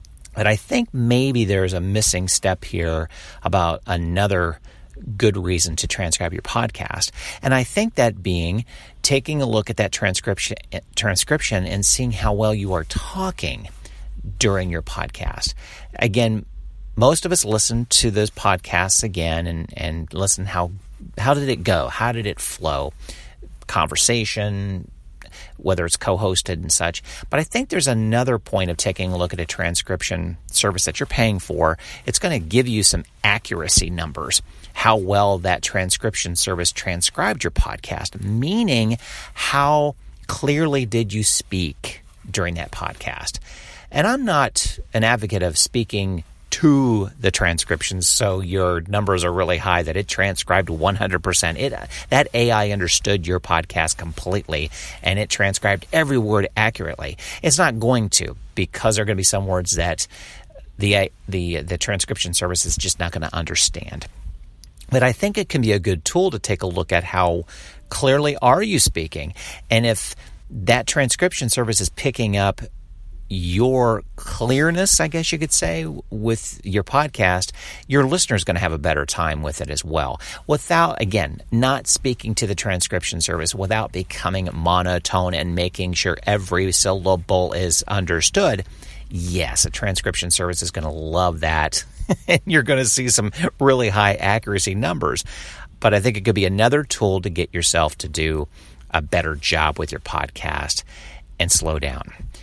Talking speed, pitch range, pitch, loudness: 160 wpm, 85-115 Hz, 95 Hz, -20 LUFS